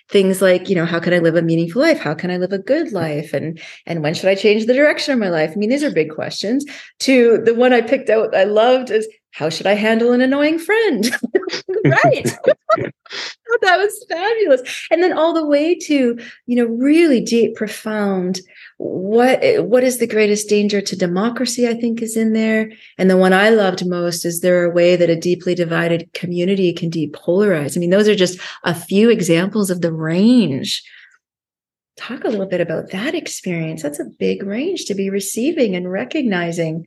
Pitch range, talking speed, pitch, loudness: 175-255 Hz, 200 wpm, 210 Hz, -16 LUFS